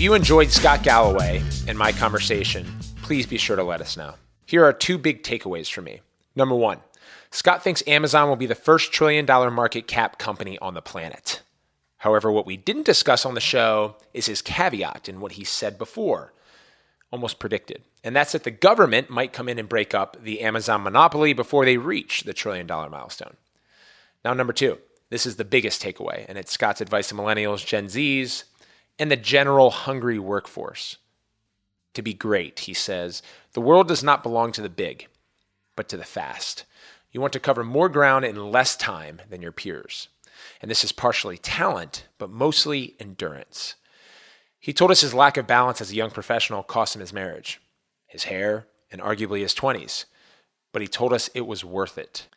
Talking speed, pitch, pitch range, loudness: 185 wpm, 115 Hz, 105-135 Hz, -21 LUFS